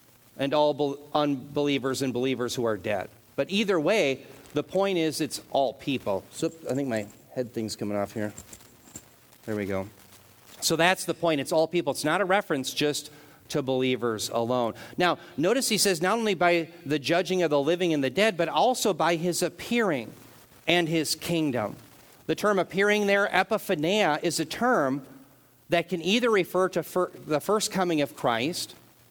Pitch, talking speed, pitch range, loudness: 150 Hz, 175 wpm, 130-180 Hz, -26 LUFS